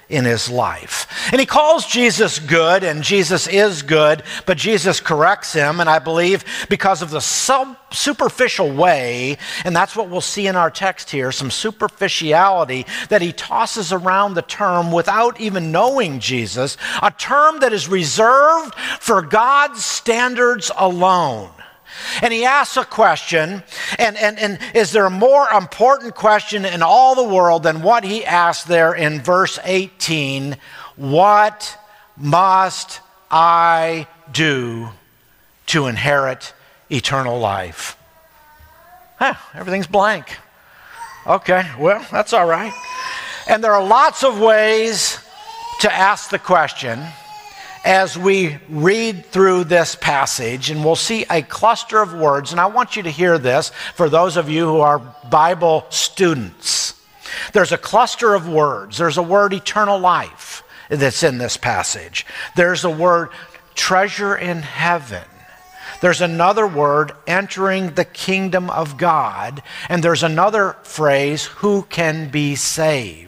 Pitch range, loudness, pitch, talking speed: 155-215 Hz, -16 LUFS, 185 Hz, 140 wpm